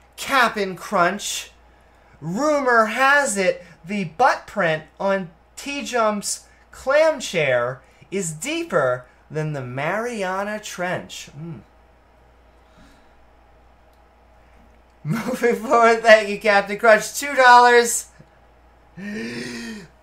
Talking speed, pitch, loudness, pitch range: 85 wpm, 200 Hz, -19 LUFS, 155-235 Hz